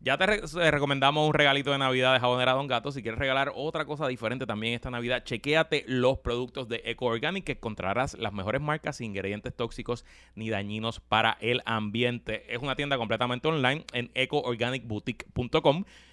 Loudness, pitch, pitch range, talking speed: -28 LUFS, 125 Hz, 115-140 Hz, 170 wpm